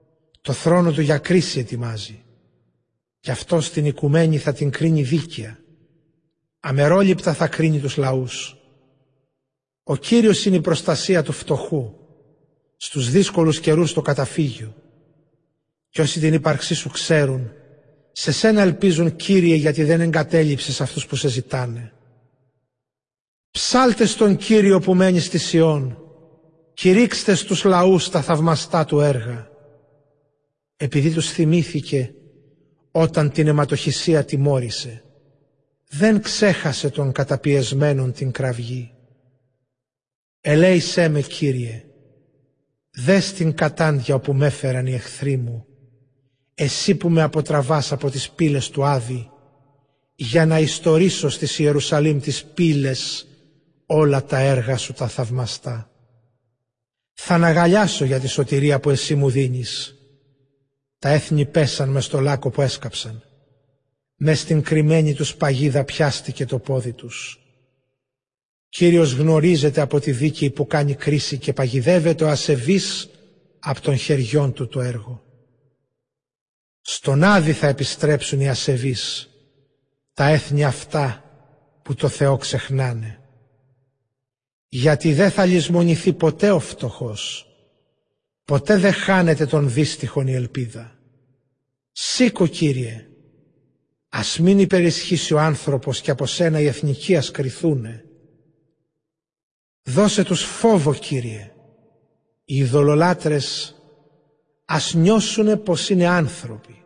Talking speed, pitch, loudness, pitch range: 115 wpm, 145 Hz, -19 LUFS, 135-160 Hz